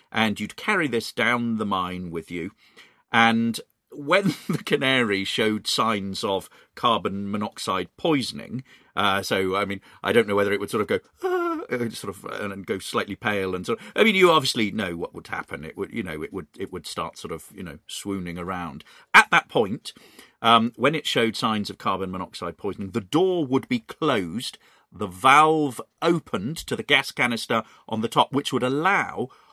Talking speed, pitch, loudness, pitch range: 195 wpm, 115 Hz, -23 LUFS, 100-135 Hz